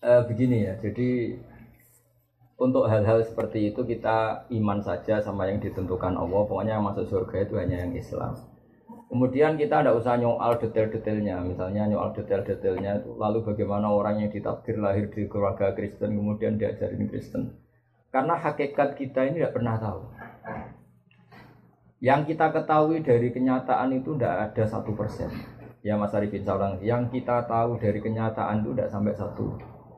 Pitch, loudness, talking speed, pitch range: 110 Hz, -26 LUFS, 150 wpm, 105-120 Hz